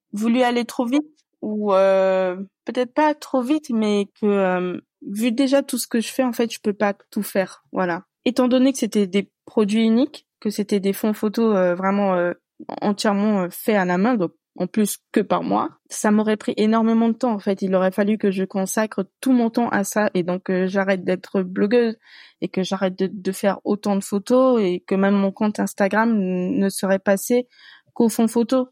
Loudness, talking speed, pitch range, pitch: -21 LUFS, 210 wpm, 195-240 Hz, 210 Hz